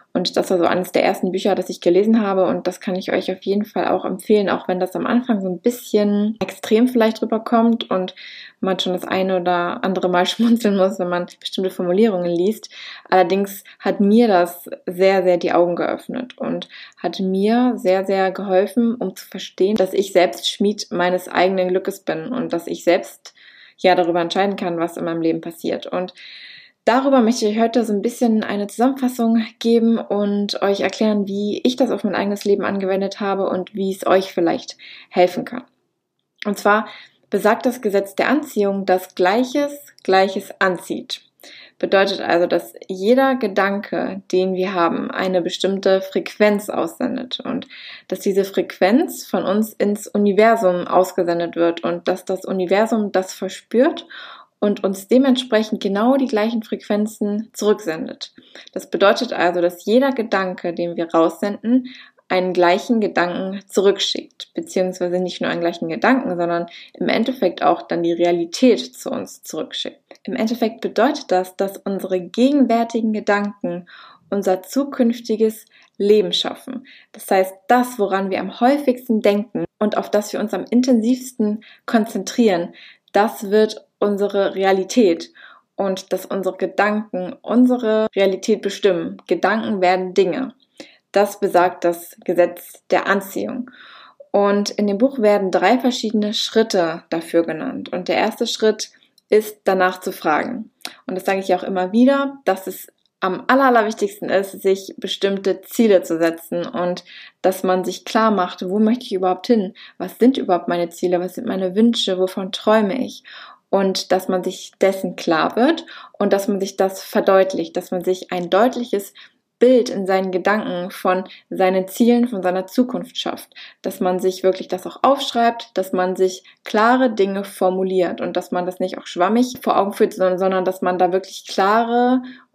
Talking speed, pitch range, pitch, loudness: 165 wpm, 185-225 Hz, 195 Hz, -19 LUFS